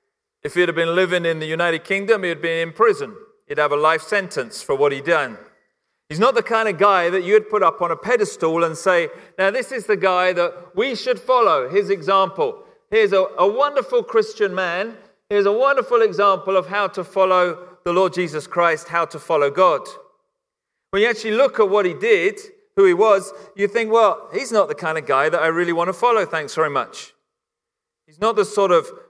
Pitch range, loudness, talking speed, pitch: 175-275 Hz, -19 LUFS, 215 wpm, 200 Hz